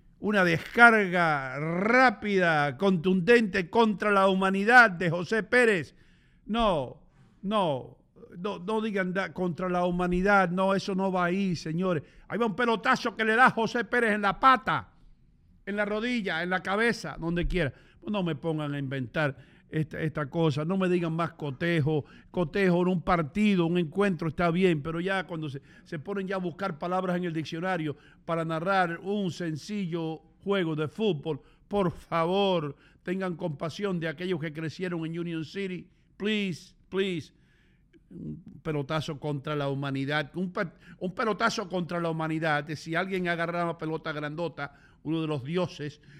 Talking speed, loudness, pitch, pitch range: 155 wpm, -27 LUFS, 180 Hz, 160-195 Hz